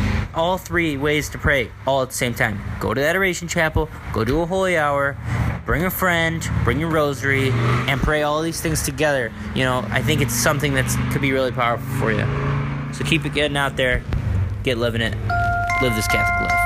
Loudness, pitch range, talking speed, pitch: -20 LUFS, 115-150 Hz, 210 wpm, 130 Hz